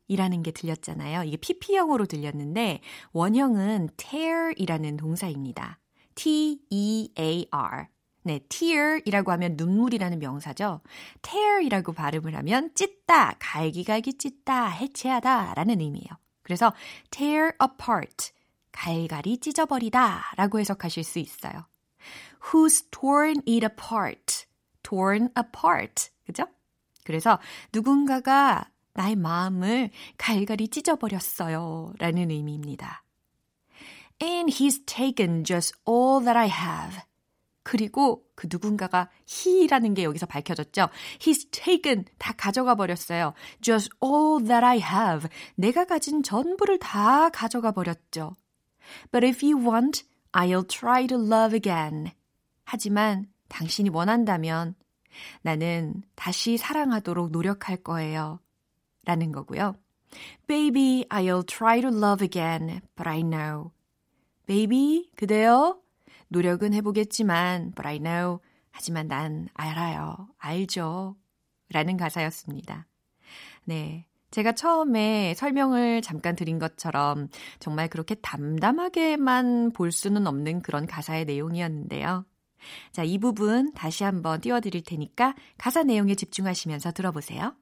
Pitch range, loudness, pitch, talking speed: 165-250 Hz, -25 LUFS, 200 Hz, 320 characters per minute